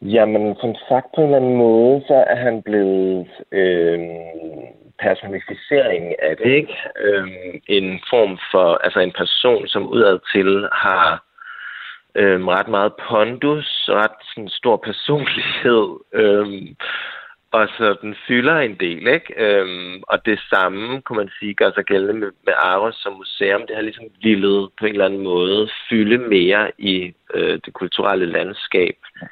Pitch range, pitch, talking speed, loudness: 95-120 Hz, 105 Hz, 155 wpm, -17 LUFS